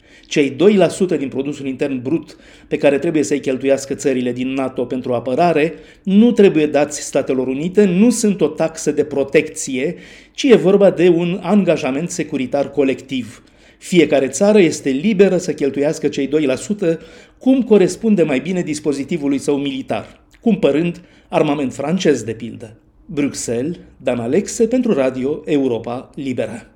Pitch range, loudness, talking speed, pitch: 135-180 Hz, -17 LUFS, 140 wpm, 150 Hz